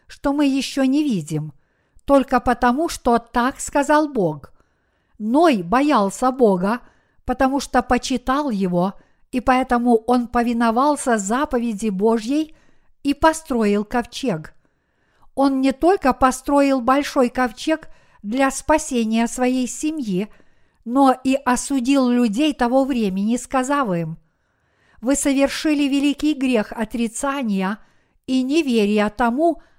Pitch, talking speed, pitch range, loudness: 255 Hz, 105 wpm, 230-280 Hz, -19 LUFS